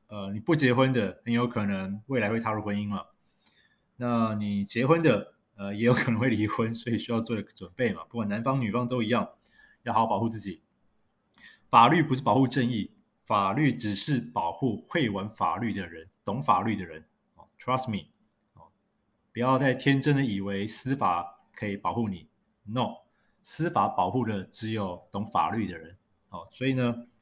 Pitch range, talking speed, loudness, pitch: 100-125 Hz, 270 characters per minute, -27 LUFS, 115 Hz